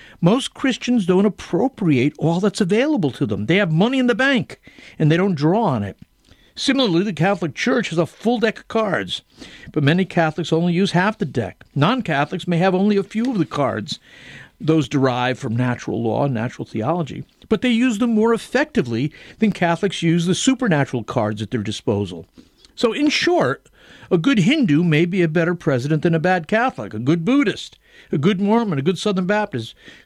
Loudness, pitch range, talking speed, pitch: -19 LUFS, 150-225 Hz, 195 wpm, 180 Hz